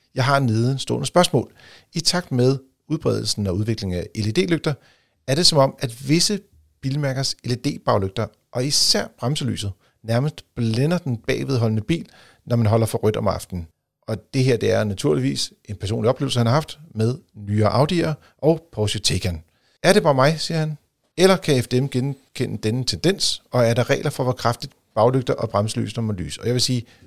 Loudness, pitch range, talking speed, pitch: -21 LUFS, 110-140 Hz, 185 wpm, 125 Hz